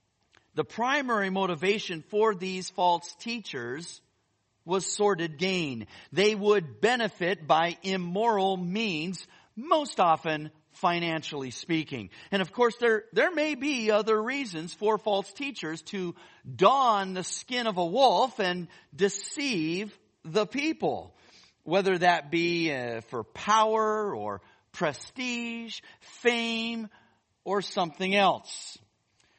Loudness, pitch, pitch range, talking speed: -28 LUFS, 190 Hz, 165-220 Hz, 110 wpm